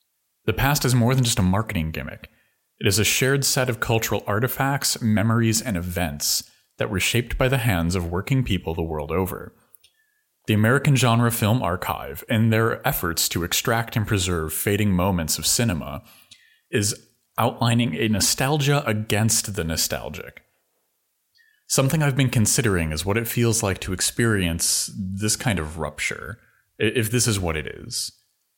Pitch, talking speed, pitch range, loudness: 110 Hz, 160 wpm, 95-125 Hz, -22 LUFS